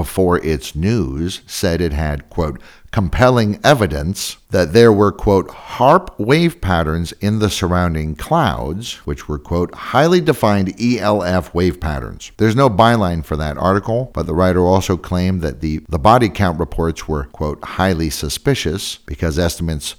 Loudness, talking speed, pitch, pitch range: -16 LUFS, 155 wpm, 90 Hz, 80-105 Hz